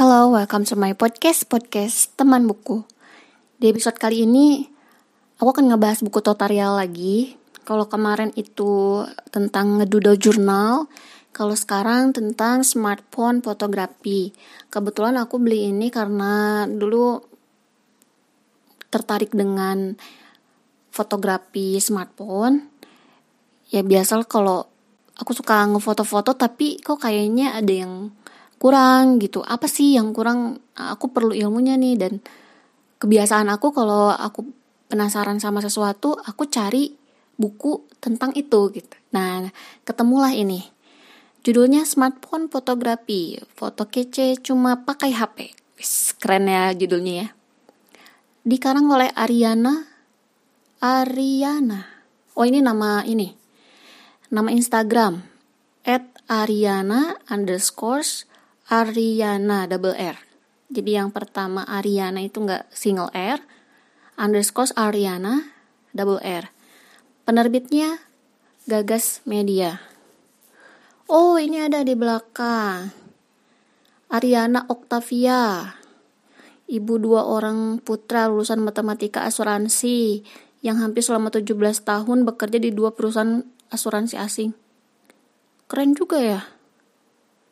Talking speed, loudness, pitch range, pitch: 100 wpm, -20 LUFS, 210-255 Hz, 230 Hz